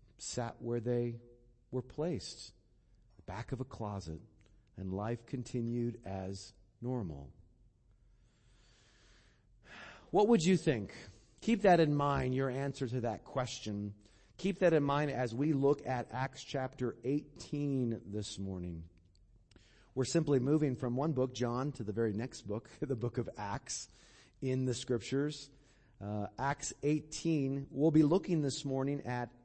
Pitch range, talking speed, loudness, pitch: 110-140 Hz, 140 wpm, -35 LUFS, 120 Hz